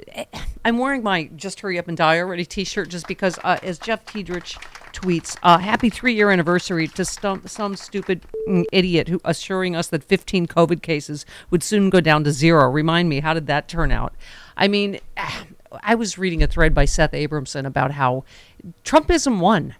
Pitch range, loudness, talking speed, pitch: 160-195 Hz, -20 LUFS, 185 wpm, 175 Hz